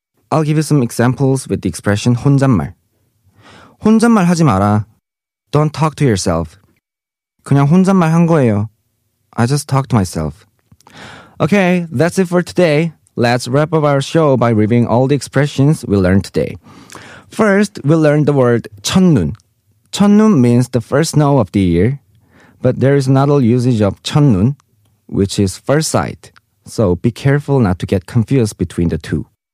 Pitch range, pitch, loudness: 105-145 Hz, 125 Hz, -13 LUFS